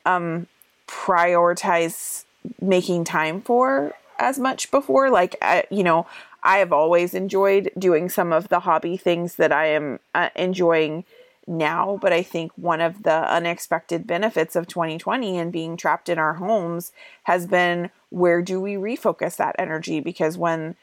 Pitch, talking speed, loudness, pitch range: 175 Hz, 155 wpm, -21 LUFS, 165-190 Hz